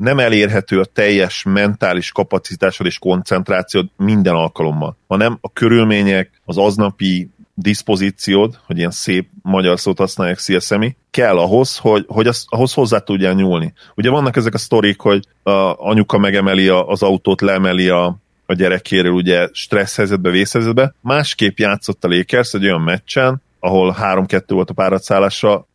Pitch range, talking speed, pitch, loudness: 95-110 Hz, 145 wpm, 100 Hz, -15 LUFS